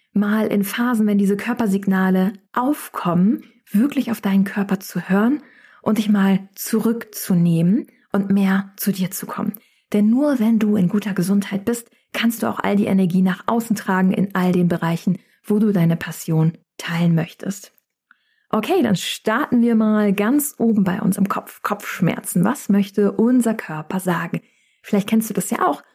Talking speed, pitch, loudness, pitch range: 170 wpm, 205 Hz, -20 LUFS, 190-230 Hz